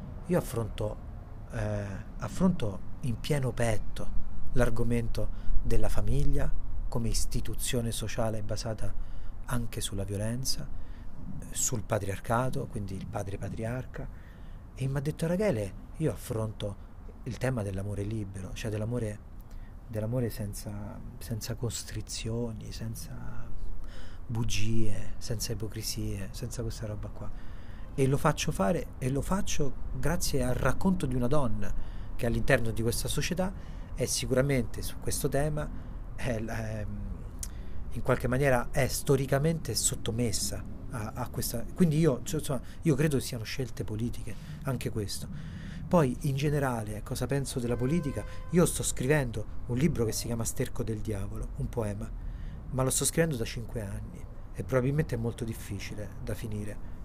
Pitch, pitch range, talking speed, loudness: 115 Hz, 105-130 Hz, 135 wpm, -32 LUFS